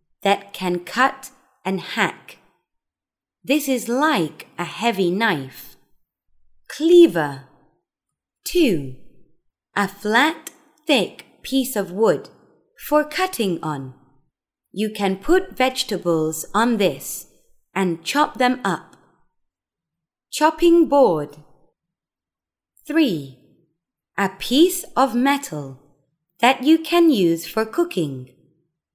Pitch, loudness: 200 Hz, -20 LUFS